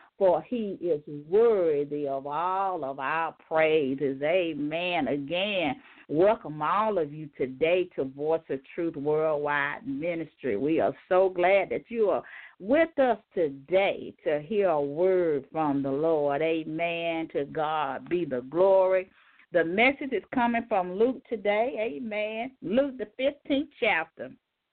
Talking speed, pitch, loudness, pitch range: 140 wpm, 175 Hz, -27 LUFS, 155-220 Hz